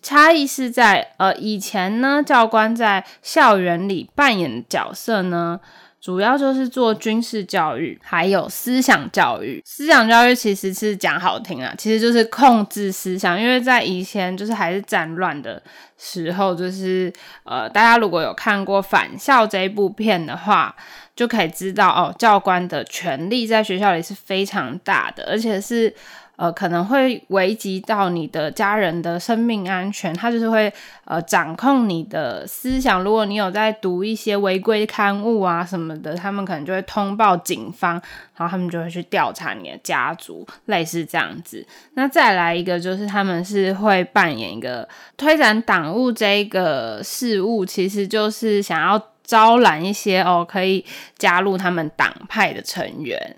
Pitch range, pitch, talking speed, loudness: 185-225 Hz, 200 Hz, 255 characters per minute, -18 LUFS